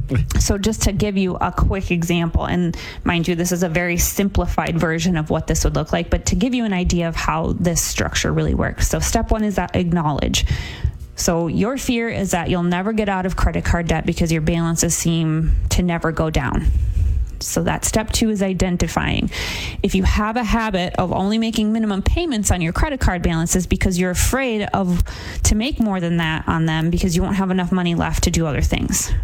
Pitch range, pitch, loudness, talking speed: 150-195 Hz, 175 Hz, -19 LUFS, 215 wpm